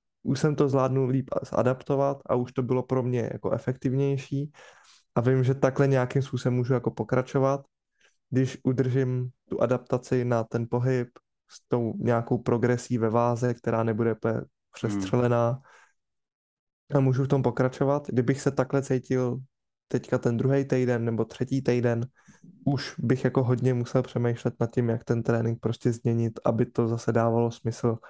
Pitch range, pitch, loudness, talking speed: 120-130 Hz, 125 Hz, -27 LUFS, 155 wpm